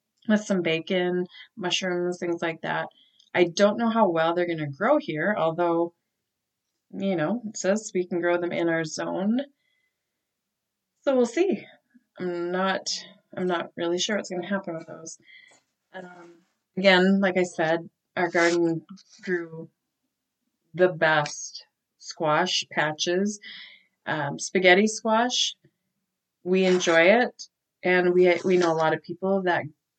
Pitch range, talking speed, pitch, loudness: 170-200 Hz, 145 wpm, 180 Hz, -24 LUFS